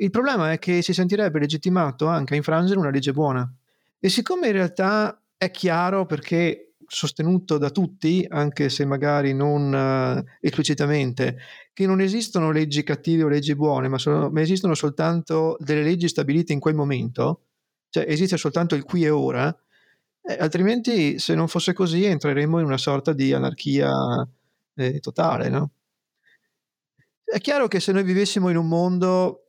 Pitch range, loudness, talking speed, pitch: 145-185 Hz, -22 LUFS, 160 wpm, 160 Hz